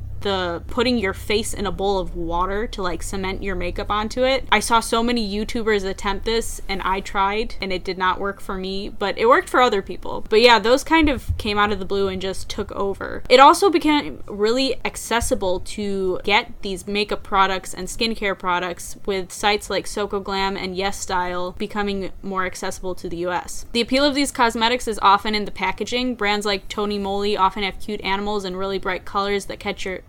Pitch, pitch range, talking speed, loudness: 200 Hz, 190-225 Hz, 210 wpm, -21 LUFS